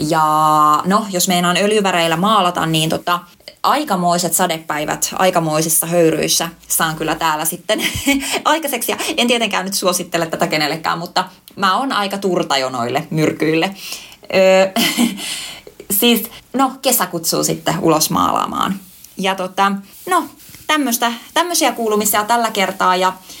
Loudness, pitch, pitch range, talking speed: -16 LUFS, 185 Hz, 165-225 Hz, 120 wpm